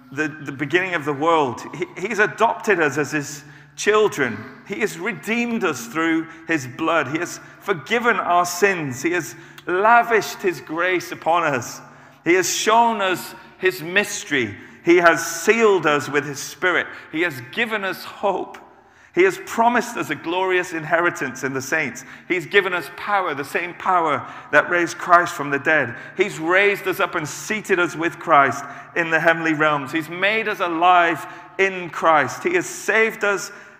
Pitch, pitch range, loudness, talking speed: 175 Hz, 155-200 Hz, -20 LUFS, 170 wpm